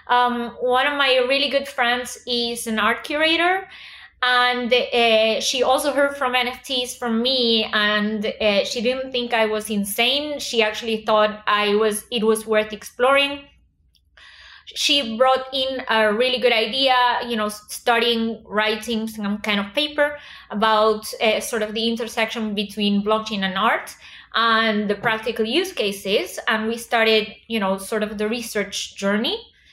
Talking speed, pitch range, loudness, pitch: 155 wpm, 215-255 Hz, -20 LUFS, 230 Hz